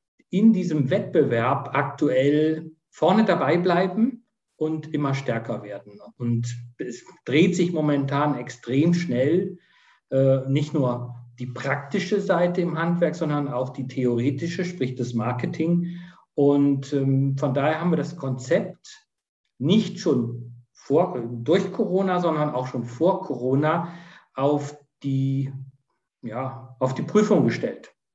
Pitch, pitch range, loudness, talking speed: 145 Hz, 130-175 Hz, -23 LUFS, 120 wpm